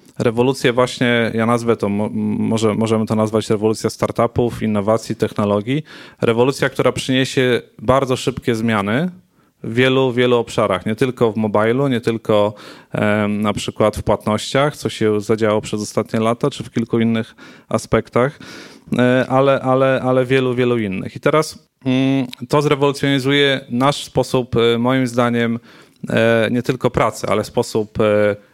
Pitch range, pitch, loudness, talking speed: 110-130 Hz, 120 Hz, -17 LUFS, 130 wpm